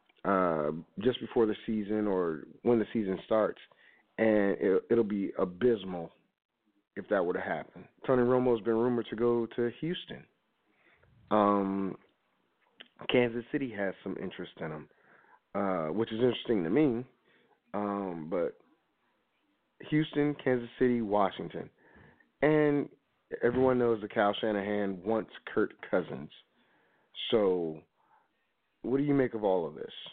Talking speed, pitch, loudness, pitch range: 130 wpm, 115 Hz, -31 LUFS, 100-125 Hz